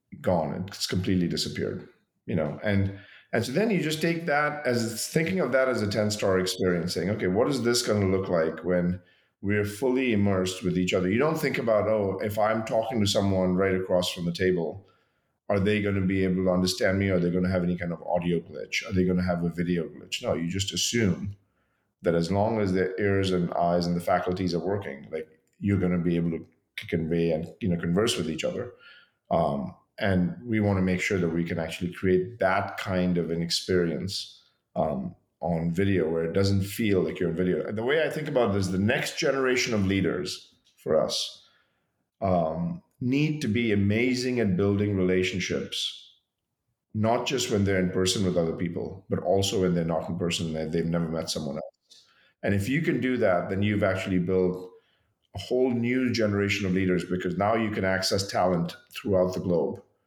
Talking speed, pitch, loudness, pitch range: 210 wpm, 95 Hz, -27 LUFS, 90-105 Hz